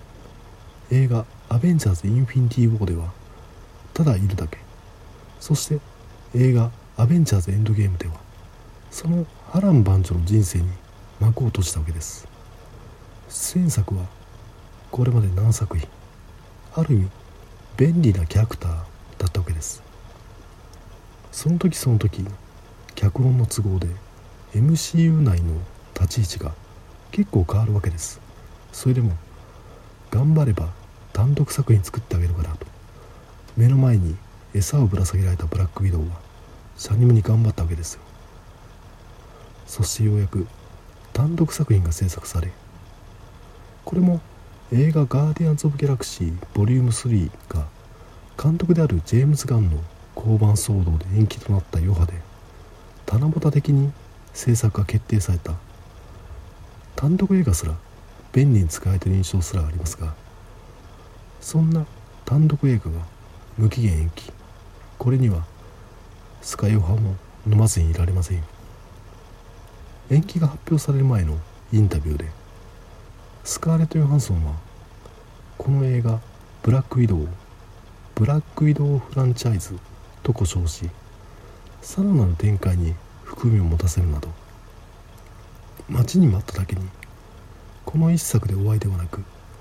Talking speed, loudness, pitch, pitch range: 285 characters per minute, -21 LUFS, 100 Hz, 90-115 Hz